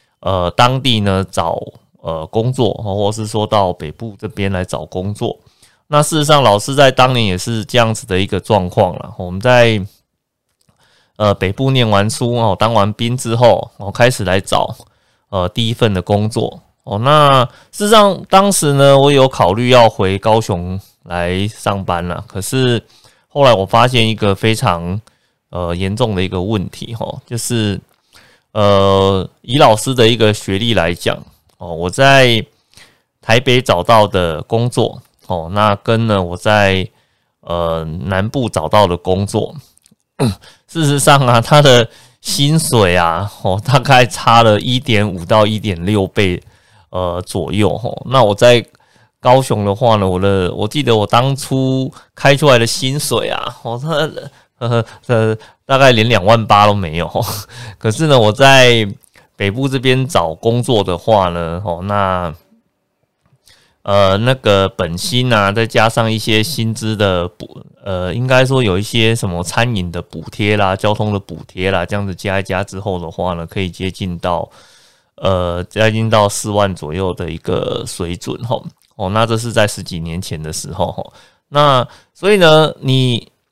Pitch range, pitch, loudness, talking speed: 95-120 Hz, 105 Hz, -14 LUFS, 225 characters per minute